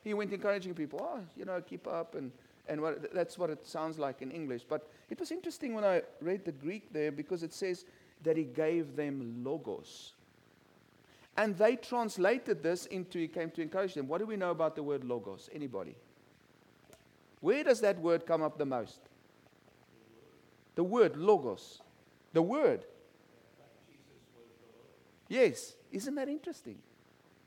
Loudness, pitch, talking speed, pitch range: -35 LUFS, 175 Hz, 160 wpm, 155-215 Hz